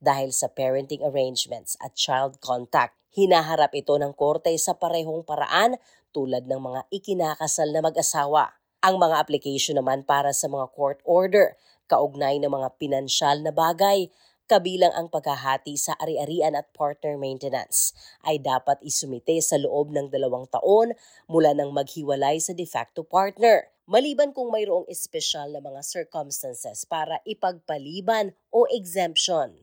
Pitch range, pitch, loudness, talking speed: 140-175 Hz, 150 Hz, -24 LUFS, 140 wpm